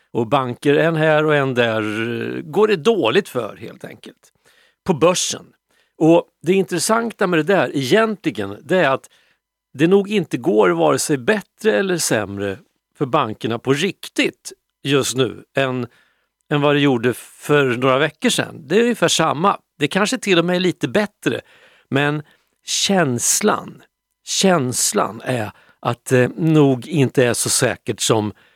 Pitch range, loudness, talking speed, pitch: 125-185 Hz, -18 LUFS, 155 wpm, 150 Hz